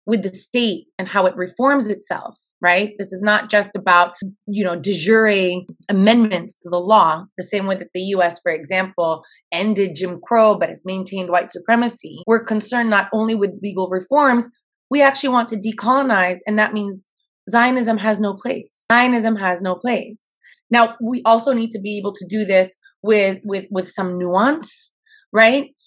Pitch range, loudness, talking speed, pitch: 185-230 Hz, -18 LUFS, 180 wpm, 205 Hz